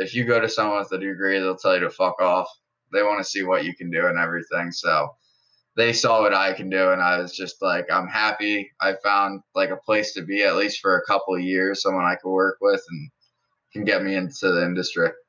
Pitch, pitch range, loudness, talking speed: 95 Hz, 95-110 Hz, -22 LUFS, 250 wpm